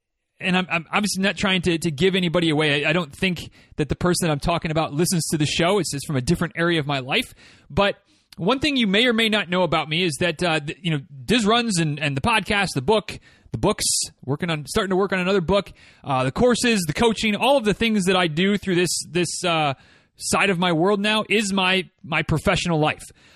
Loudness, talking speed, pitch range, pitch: -21 LUFS, 245 wpm, 160-200 Hz, 180 Hz